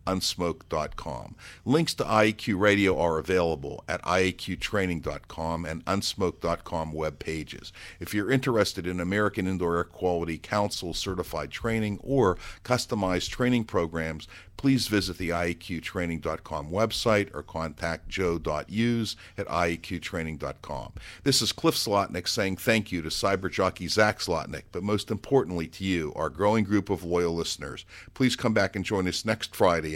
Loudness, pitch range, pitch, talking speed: -28 LUFS, 85-105 Hz, 95 Hz, 140 wpm